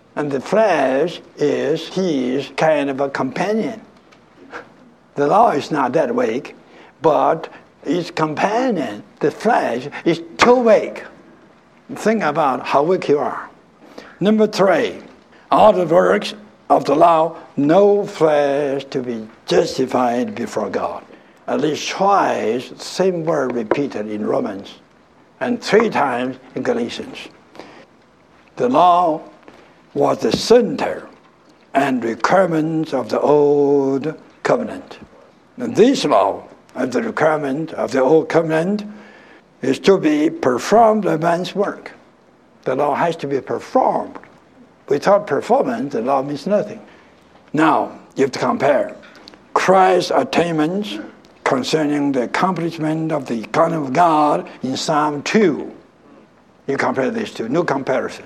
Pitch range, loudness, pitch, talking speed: 140-195 Hz, -17 LUFS, 160 Hz, 125 wpm